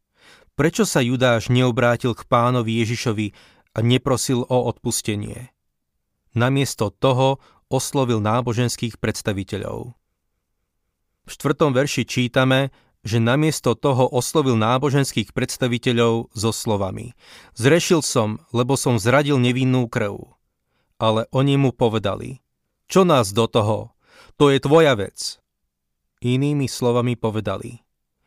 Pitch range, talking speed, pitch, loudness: 110-130 Hz, 105 wpm, 120 Hz, -20 LUFS